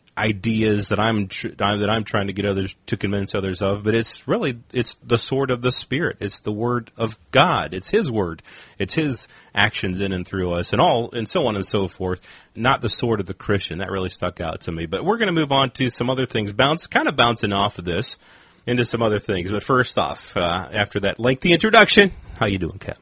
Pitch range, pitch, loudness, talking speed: 100-125 Hz, 110 Hz, -21 LUFS, 235 wpm